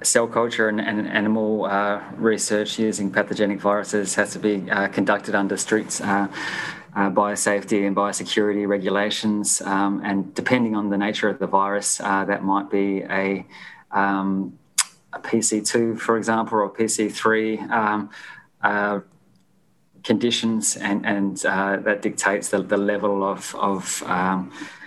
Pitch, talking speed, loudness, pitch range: 100 Hz, 140 wpm, -22 LUFS, 100-110 Hz